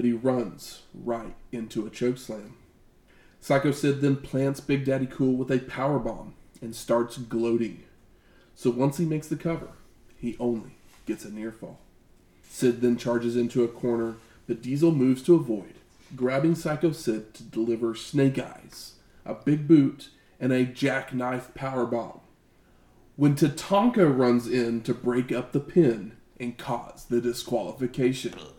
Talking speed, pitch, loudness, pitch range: 150 wpm, 125 Hz, -26 LUFS, 120-140 Hz